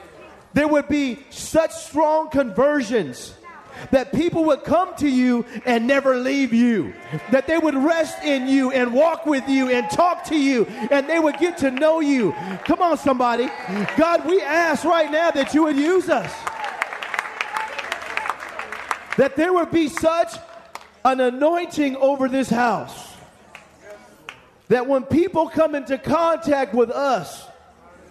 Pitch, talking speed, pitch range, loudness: 290 Hz, 145 wpm, 265-320 Hz, -20 LUFS